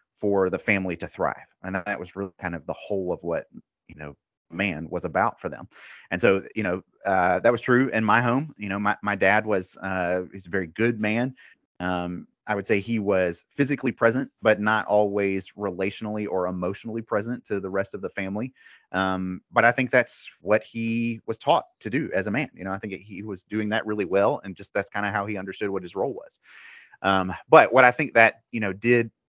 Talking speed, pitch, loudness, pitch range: 230 wpm, 105 Hz, -24 LUFS, 95-115 Hz